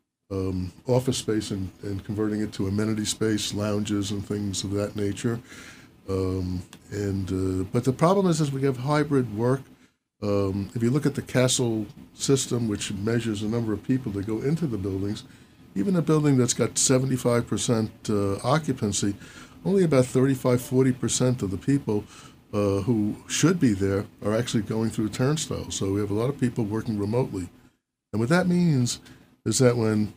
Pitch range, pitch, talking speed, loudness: 100-130 Hz, 110 Hz, 175 wpm, -25 LUFS